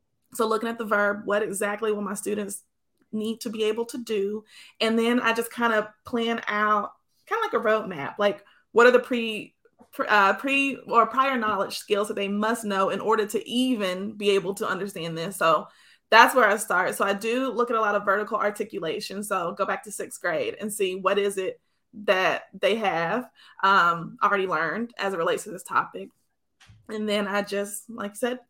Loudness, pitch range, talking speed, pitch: -25 LUFS, 200-230 Hz, 205 wpm, 215 Hz